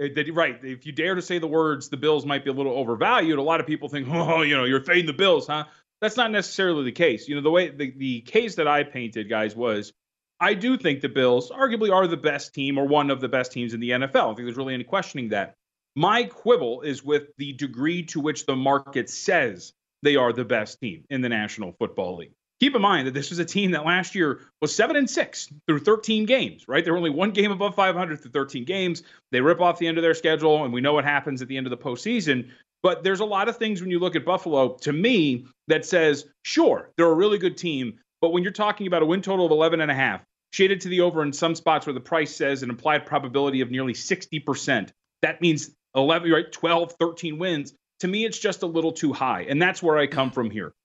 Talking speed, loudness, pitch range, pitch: 255 wpm, -23 LUFS, 140-180 Hz, 155 Hz